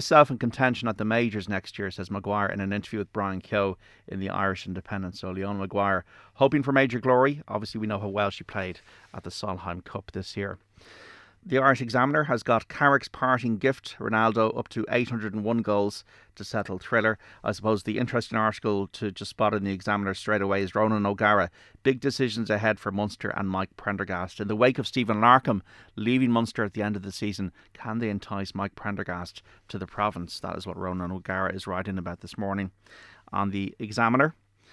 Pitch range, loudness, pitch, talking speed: 100-115 Hz, -27 LUFS, 105 Hz, 200 wpm